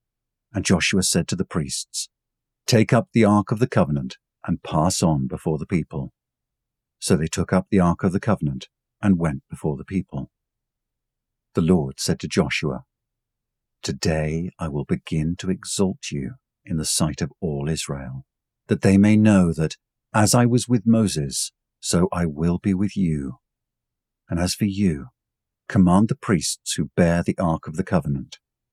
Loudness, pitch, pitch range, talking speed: -22 LUFS, 95 Hz, 80-105 Hz, 170 wpm